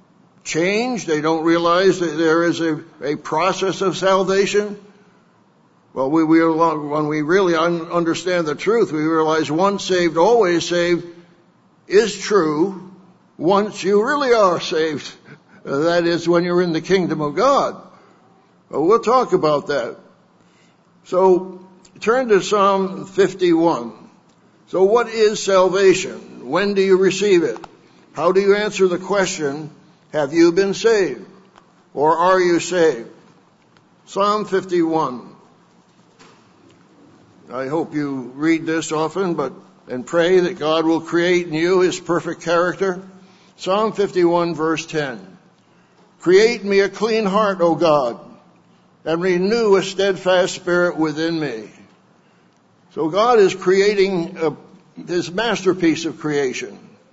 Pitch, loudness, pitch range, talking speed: 180 Hz, -18 LUFS, 165-195 Hz, 130 wpm